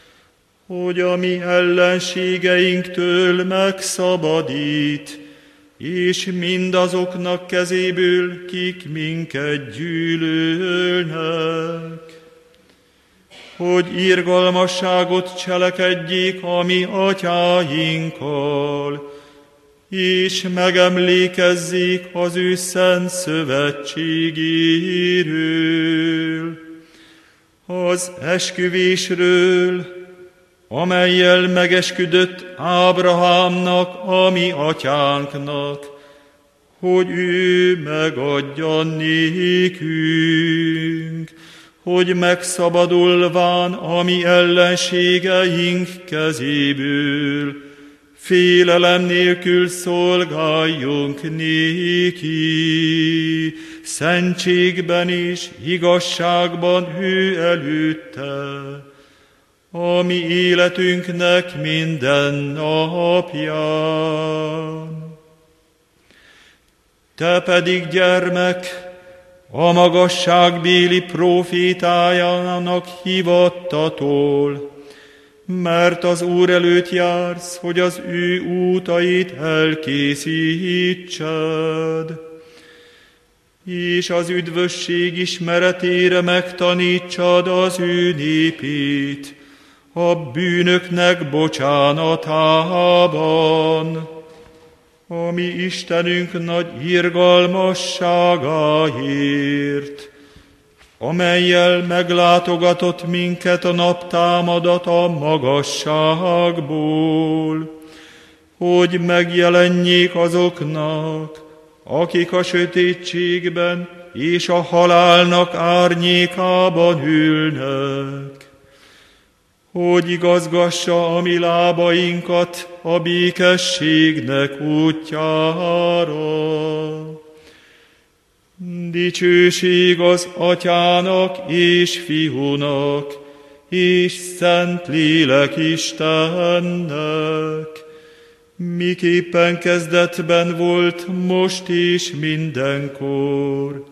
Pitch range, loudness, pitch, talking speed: 155-180 Hz, -16 LUFS, 175 Hz, 55 wpm